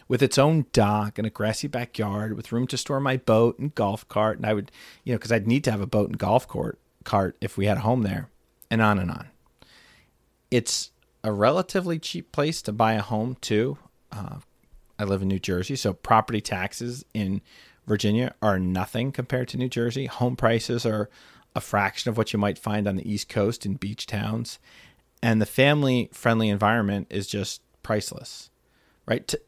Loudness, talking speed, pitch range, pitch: -25 LUFS, 195 wpm, 105-125 Hz, 110 Hz